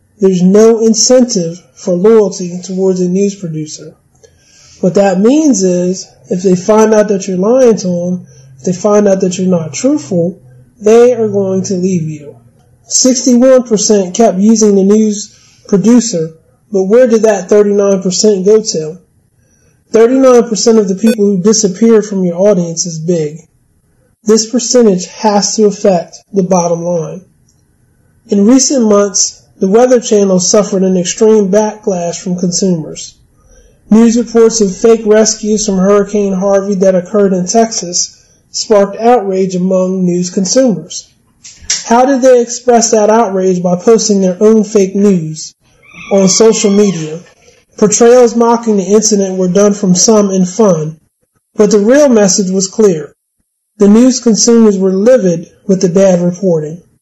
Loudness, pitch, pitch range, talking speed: -9 LUFS, 200 Hz, 180-220 Hz, 145 wpm